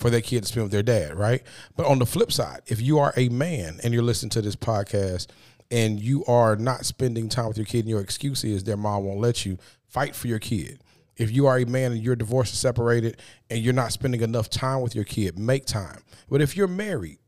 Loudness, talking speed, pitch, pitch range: -25 LUFS, 250 wpm, 120 Hz, 110-130 Hz